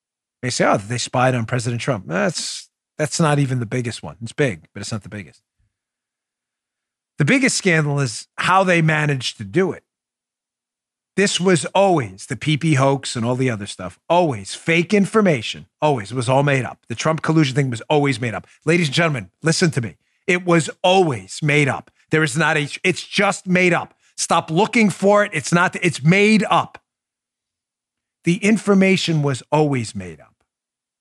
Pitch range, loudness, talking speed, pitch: 125-175 Hz, -18 LUFS, 180 wpm, 150 Hz